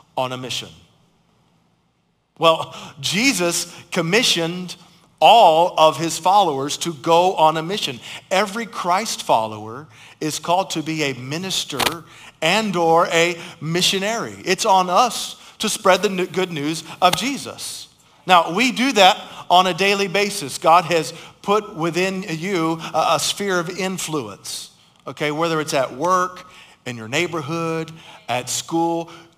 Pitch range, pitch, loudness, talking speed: 160-190 Hz, 170 Hz, -19 LUFS, 135 wpm